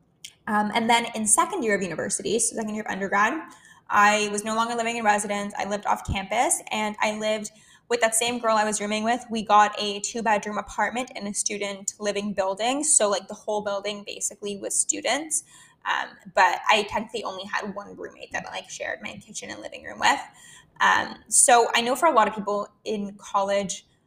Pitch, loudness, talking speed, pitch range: 210 Hz, -24 LUFS, 205 wpm, 205-230 Hz